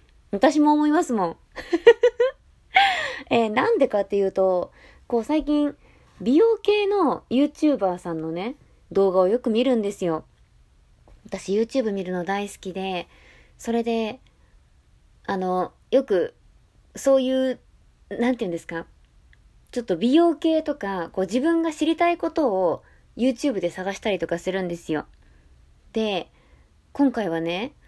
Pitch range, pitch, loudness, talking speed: 185-295 Hz, 230 Hz, -23 LUFS, 280 characters per minute